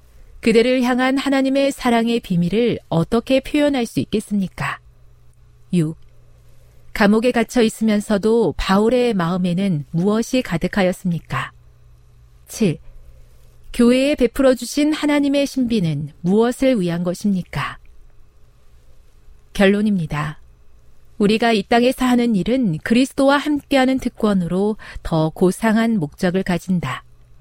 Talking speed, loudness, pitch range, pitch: 255 characters per minute, -18 LUFS, 150-240 Hz, 200 Hz